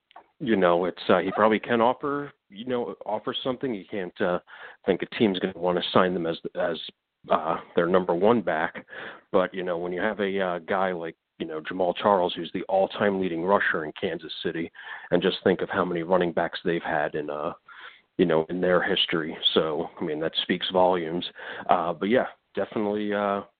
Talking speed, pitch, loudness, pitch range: 205 wpm, 95 Hz, -26 LUFS, 85-105 Hz